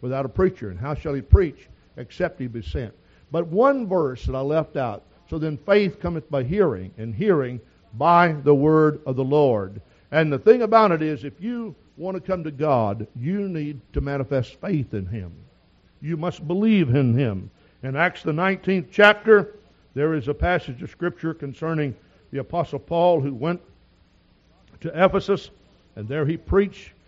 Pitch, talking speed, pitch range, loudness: 150 Hz, 180 wpm, 130-175 Hz, -22 LUFS